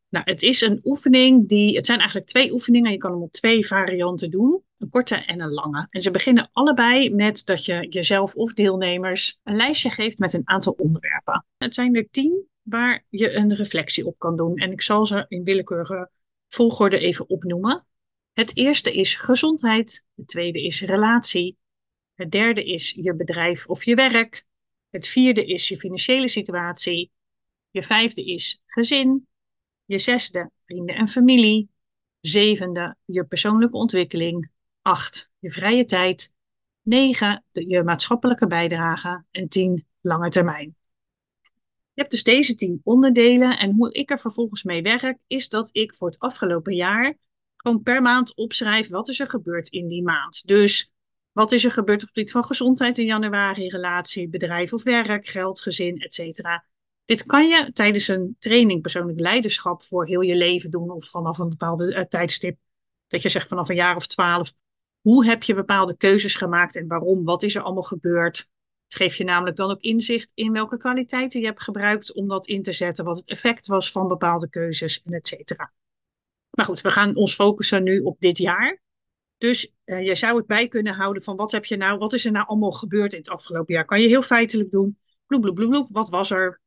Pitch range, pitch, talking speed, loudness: 180-230 Hz, 200 Hz, 185 wpm, -20 LUFS